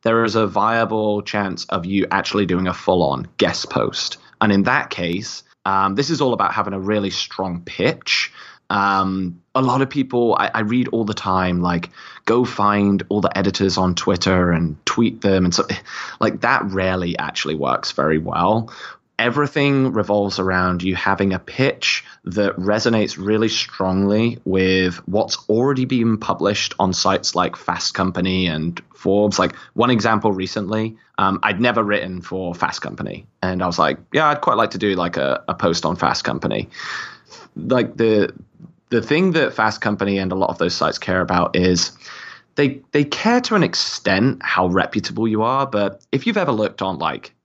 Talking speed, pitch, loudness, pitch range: 180 wpm, 100 Hz, -19 LUFS, 95-115 Hz